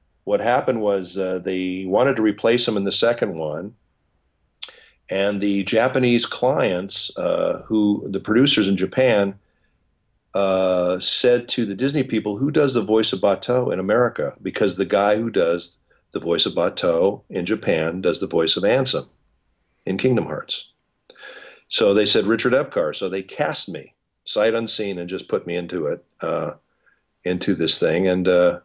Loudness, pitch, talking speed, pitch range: -21 LUFS, 100 Hz, 165 wpm, 90-110 Hz